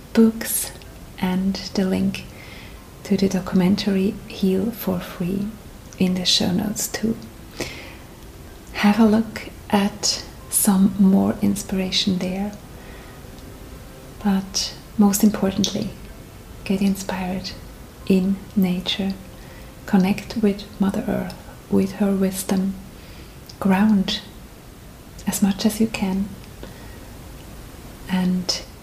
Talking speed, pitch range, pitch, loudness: 90 wpm, 190-205 Hz, 195 Hz, -21 LUFS